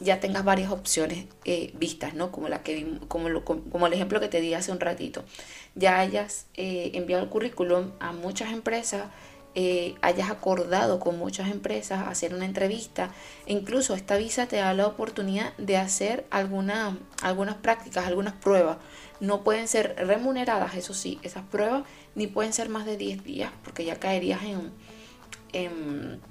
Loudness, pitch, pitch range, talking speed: -28 LUFS, 190 Hz, 175-205 Hz, 170 wpm